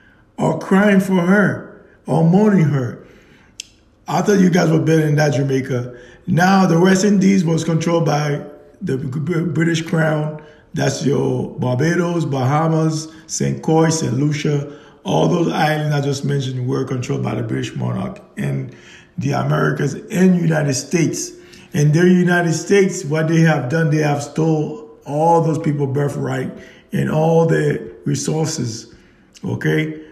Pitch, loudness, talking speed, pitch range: 155 Hz, -17 LUFS, 145 wpm, 140-170 Hz